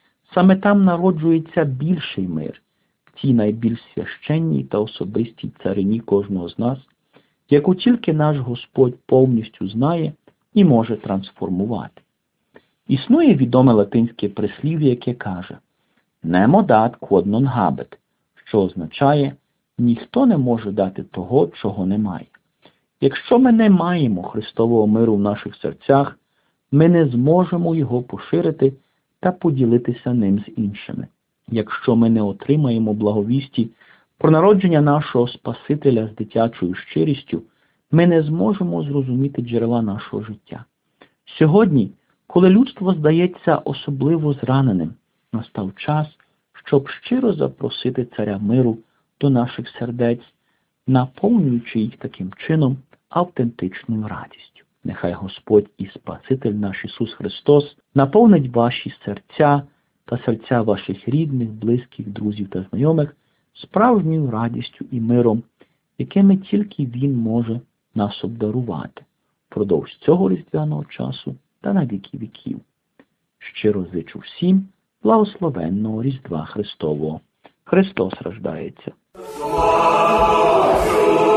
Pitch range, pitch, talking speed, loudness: 110-155 Hz, 125 Hz, 110 wpm, -19 LUFS